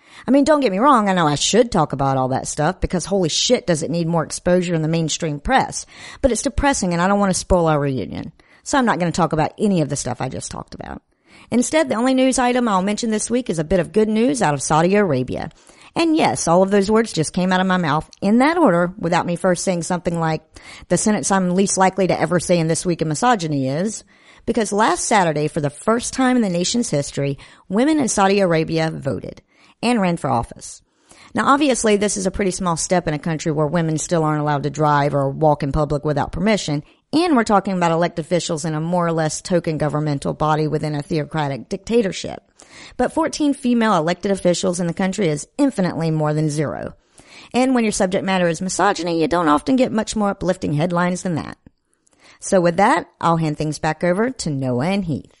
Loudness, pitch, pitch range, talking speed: -19 LUFS, 180 Hz, 155-215 Hz, 230 wpm